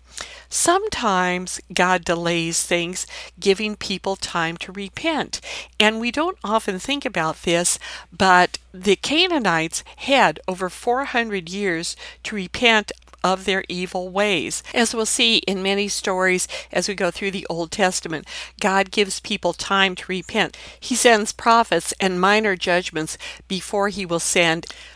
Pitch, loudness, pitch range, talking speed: 195 Hz, -20 LUFS, 180-215 Hz, 140 wpm